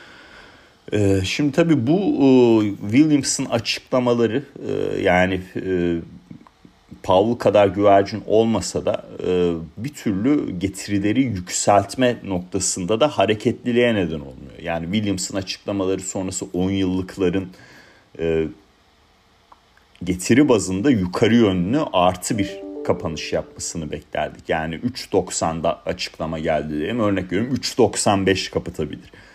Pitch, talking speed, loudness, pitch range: 100 Hz, 100 wpm, -20 LUFS, 90-115 Hz